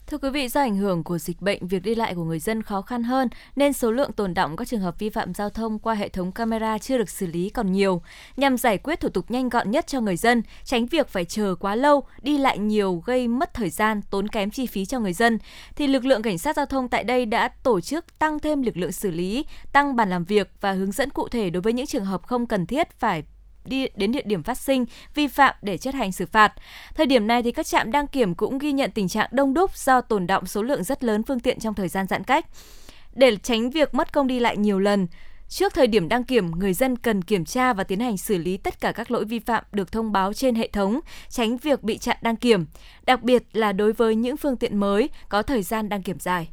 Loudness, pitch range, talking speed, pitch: -23 LUFS, 200-260 Hz, 265 wpm, 230 Hz